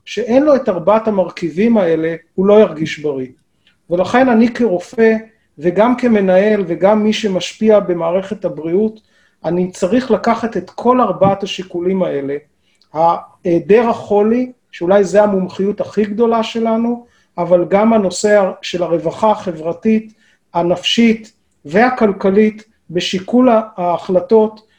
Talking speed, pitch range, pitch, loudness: 110 wpm, 180-220 Hz, 205 Hz, -14 LUFS